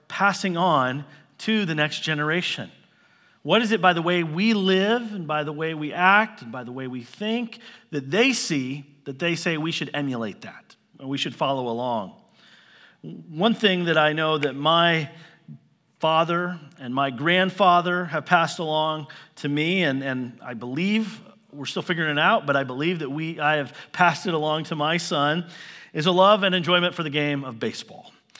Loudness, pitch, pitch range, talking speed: -23 LUFS, 160 Hz, 145-180 Hz, 190 wpm